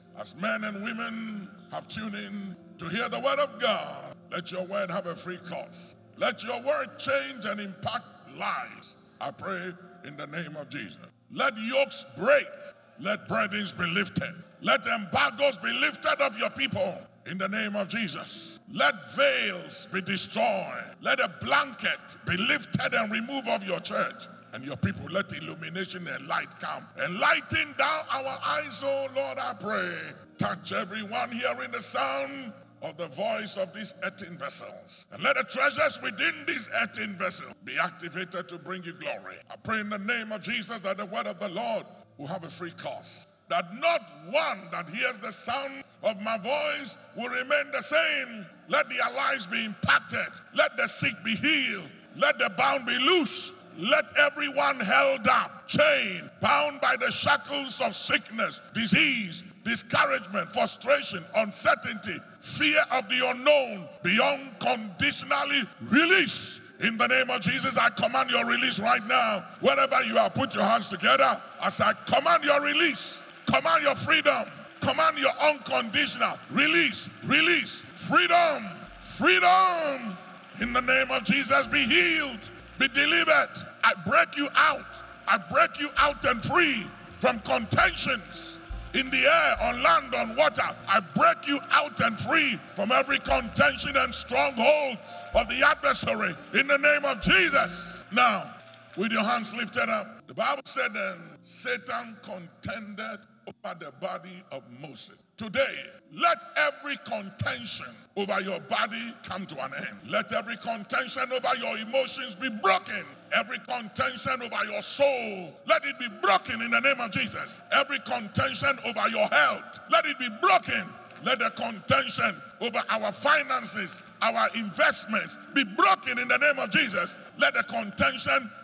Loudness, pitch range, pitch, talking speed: -25 LUFS, 195-280 Hz, 230 Hz, 155 wpm